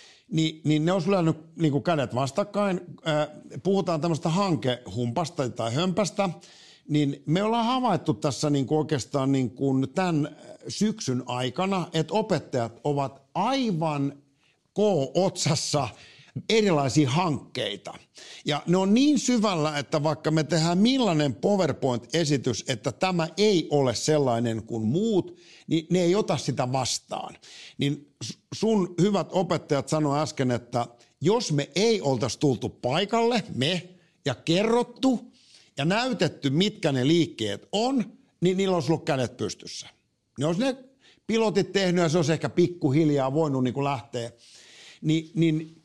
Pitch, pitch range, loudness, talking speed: 160 Hz, 140-190 Hz, -26 LUFS, 130 wpm